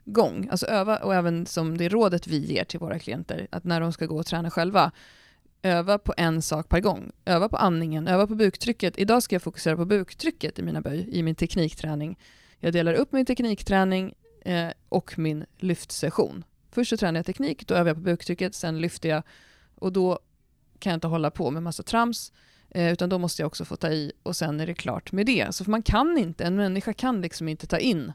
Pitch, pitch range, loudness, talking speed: 175 Hz, 165-195 Hz, -26 LUFS, 220 wpm